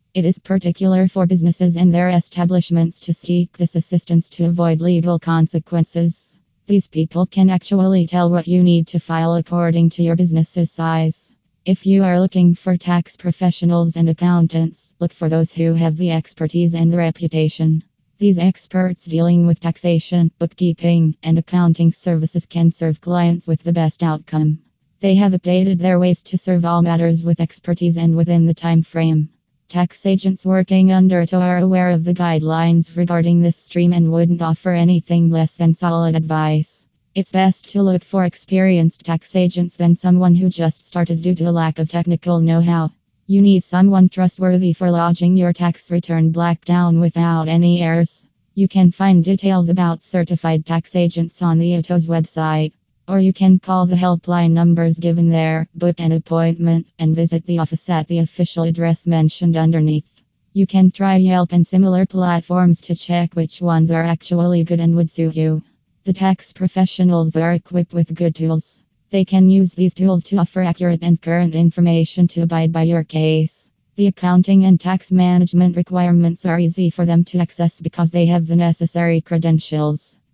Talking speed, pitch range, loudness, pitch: 175 wpm, 165-180 Hz, -16 LUFS, 170 Hz